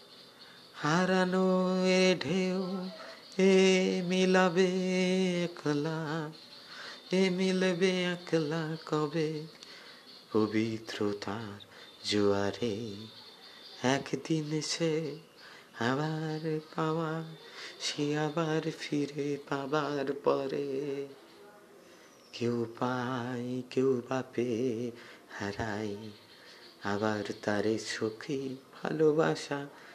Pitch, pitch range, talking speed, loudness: 150 Hz, 120-165 Hz, 60 wpm, -31 LUFS